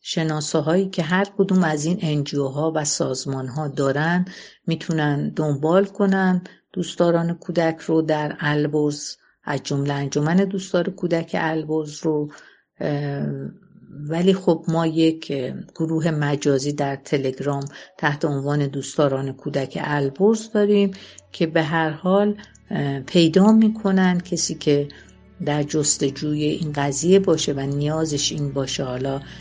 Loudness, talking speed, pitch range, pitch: -21 LUFS, 120 wpm, 145-175 Hz, 155 Hz